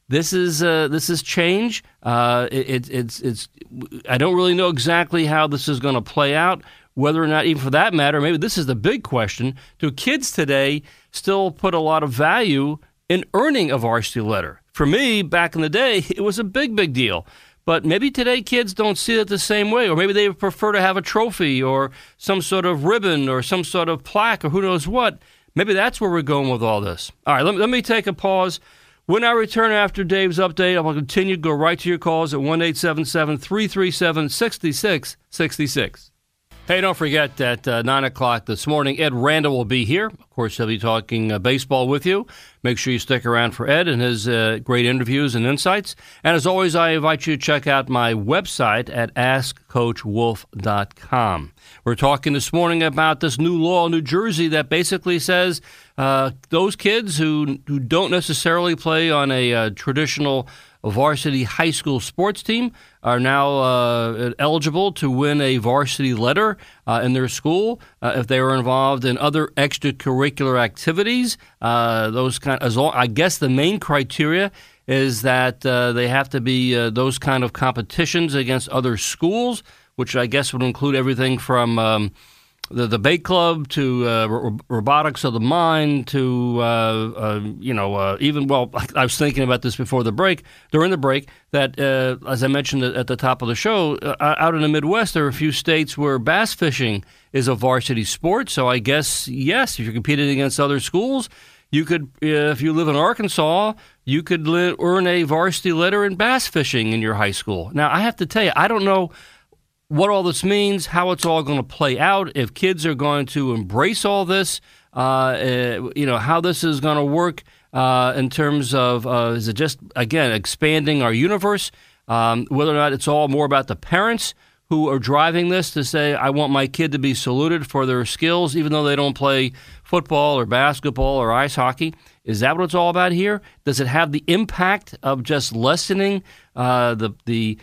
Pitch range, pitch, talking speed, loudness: 125-175 Hz, 145 Hz, 200 wpm, -19 LUFS